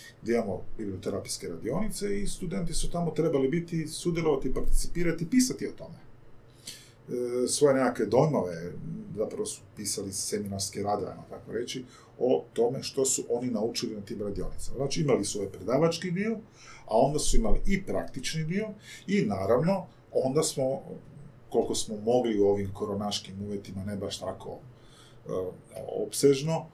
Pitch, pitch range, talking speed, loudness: 130 Hz, 105-165 Hz, 140 wpm, -30 LUFS